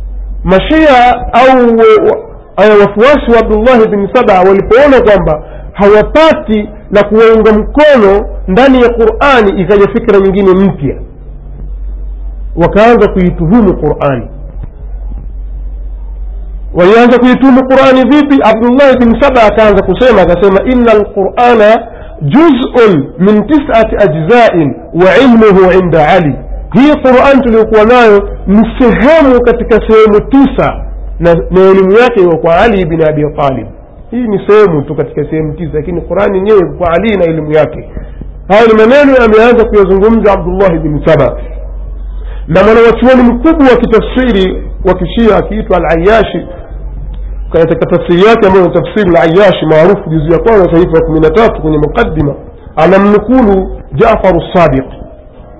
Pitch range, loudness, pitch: 160-230 Hz, -6 LUFS, 200 Hz